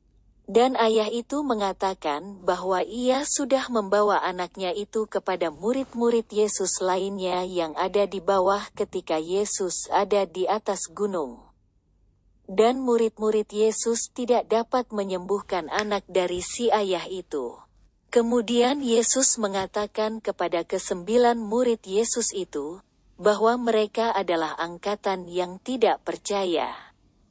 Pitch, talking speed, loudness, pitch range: 205 Hz, 110 wpm, -25 LUFS, 185-230 Hz